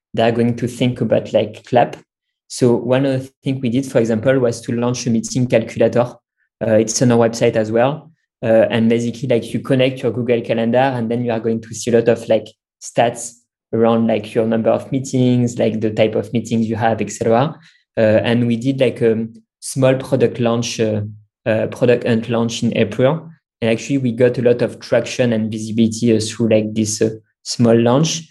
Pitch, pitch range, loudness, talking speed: 115 Hz, 115-125 Hz, -17 LUFS, 210 wpm